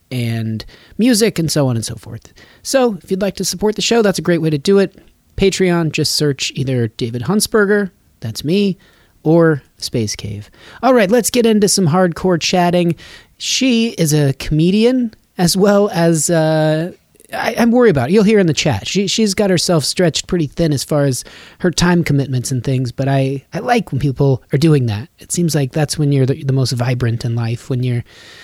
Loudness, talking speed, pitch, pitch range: -15 LUFS, 205 wpm, 165 Hz, 135-195 Hz